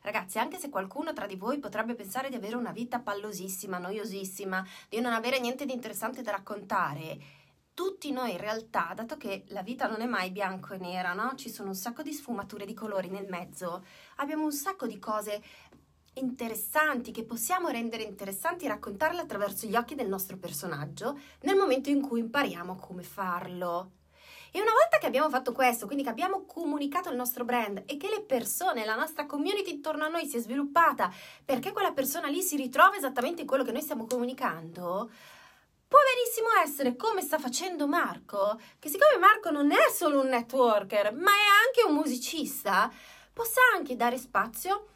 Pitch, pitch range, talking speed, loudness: 250 Hz, 210-310 Hz, 185 wpm, -29 LUFS